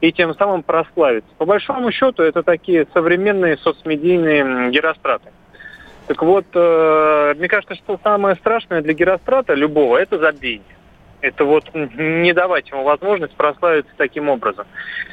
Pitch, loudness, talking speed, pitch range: 170 Hz, -16 LUFS, 130 wpm, 155-195 Hz